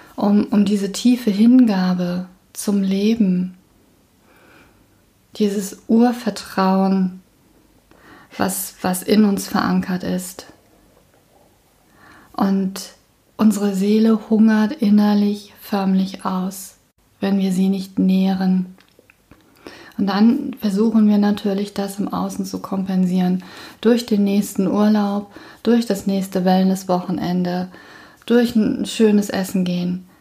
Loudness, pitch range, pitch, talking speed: -18 LUFS, 190-215 Hz, 200 Hz, 100 wpm